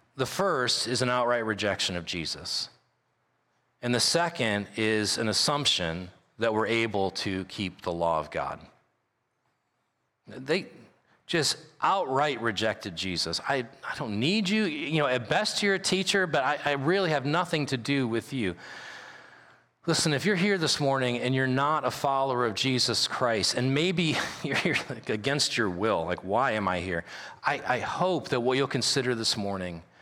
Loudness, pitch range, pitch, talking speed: -27 LUFS, 105-150 Hz, 125 Hz, 170 wpm